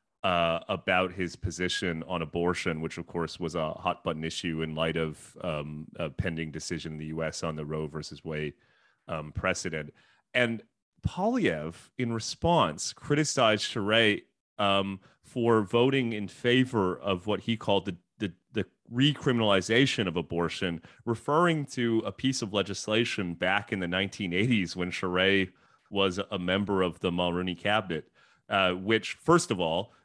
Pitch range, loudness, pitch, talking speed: 85-110 Hz, -29 LUFS, 95 Hz, 150 wpm